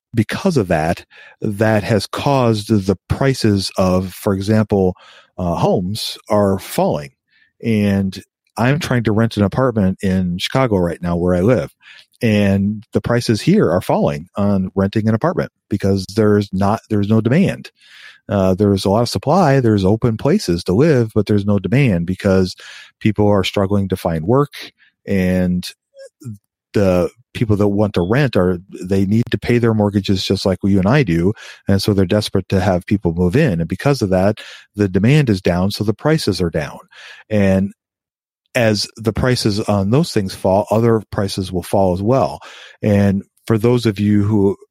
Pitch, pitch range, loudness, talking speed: 105 Hz, 95-115 Hz, -17 LUFS, 175 wpm